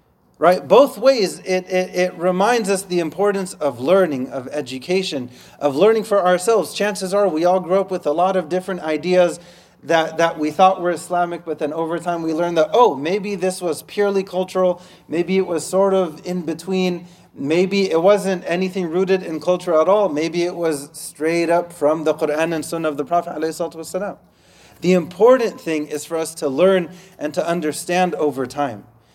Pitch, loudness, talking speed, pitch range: 175 Hz, -19 LUFS, 185 wpm, 160-190 Hz